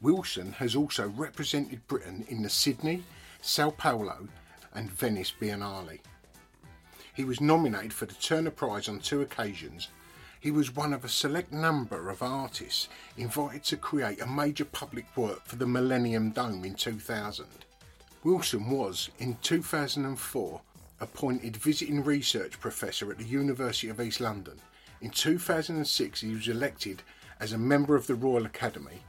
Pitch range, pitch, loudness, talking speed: 110-145 Hz, 125 Hz, -31 LUFS, 145 wpm